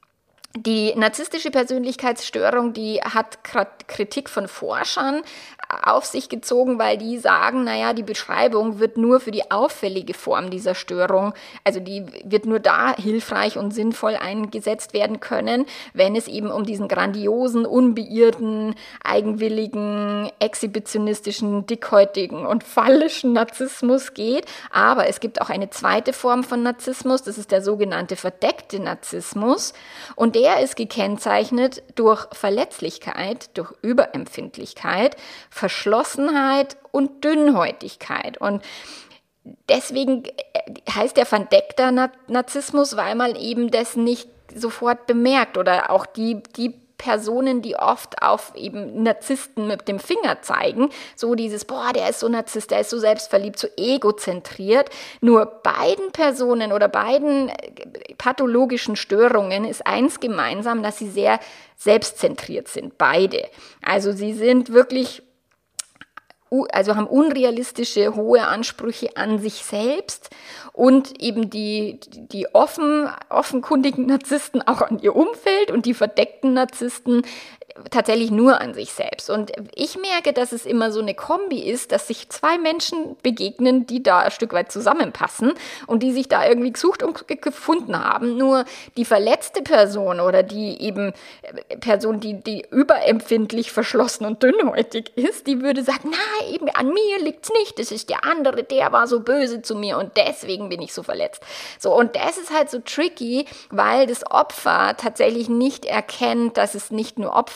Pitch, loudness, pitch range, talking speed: 240 Hz, -20 LUFS, 215-275 Hz, 140 wpm